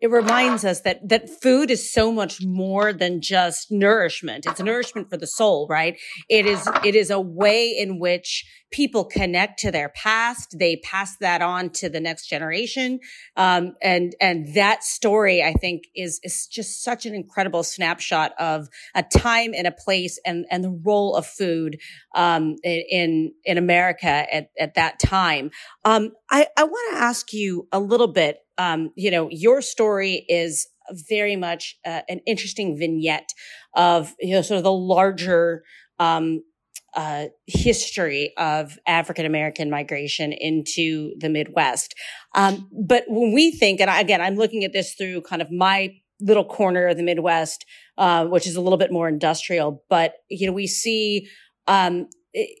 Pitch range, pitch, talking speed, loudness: 170-210 Hz, 185 Hz, 170 wpm, -21 LUFS